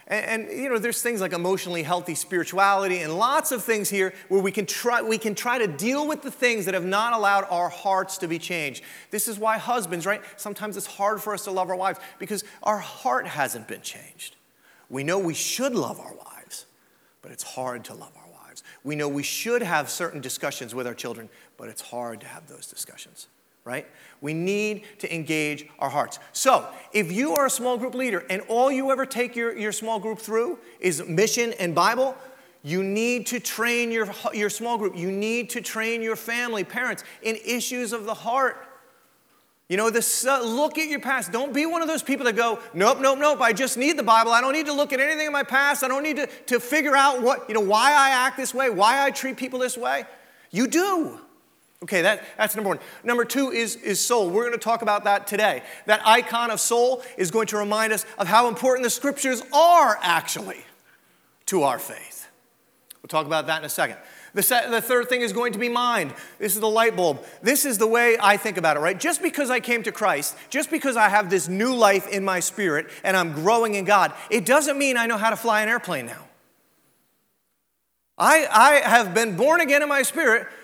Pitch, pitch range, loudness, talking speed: 225 Hz, 195-255 Hz, -22 LUFS, 225 wpm